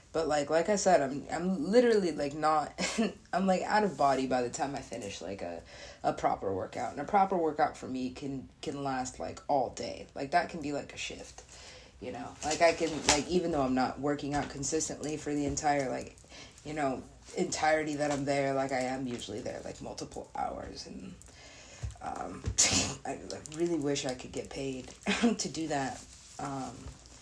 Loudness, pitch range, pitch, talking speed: -32 LUFS, 135-165 Hz, 145 Hz, 195 wpm